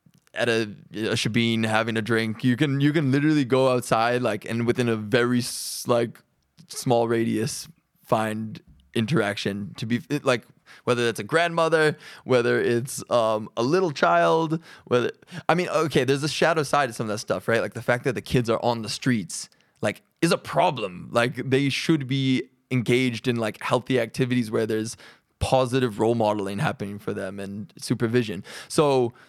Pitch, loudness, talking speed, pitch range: 125 Hz, -24 LUFS, 175 wpm, 115-145 Hz